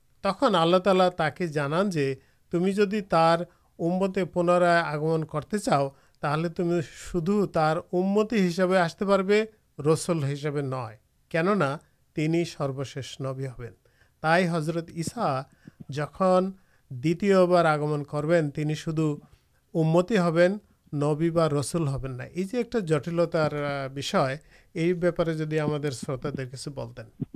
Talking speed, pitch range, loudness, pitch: 100 wpm, 145-180 Hz, -26 LUFS, 165 Hz